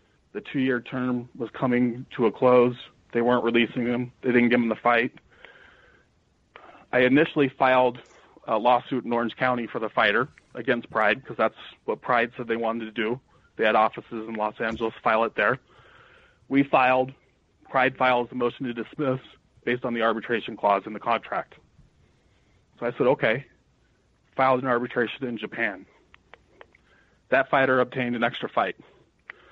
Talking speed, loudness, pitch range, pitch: 165 wpm, -24 LUFS, 115-130 Hz, 125 Hz